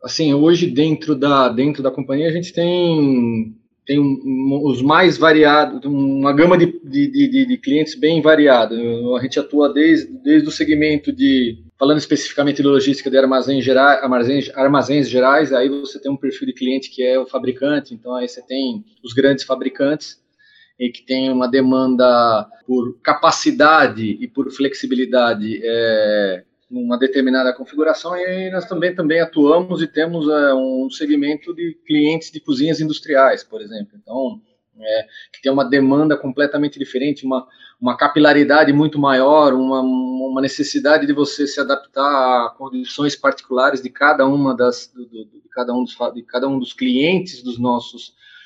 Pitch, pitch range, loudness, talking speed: 140 Hz, 130-155 Hz, -16 LUFS, 160 wpm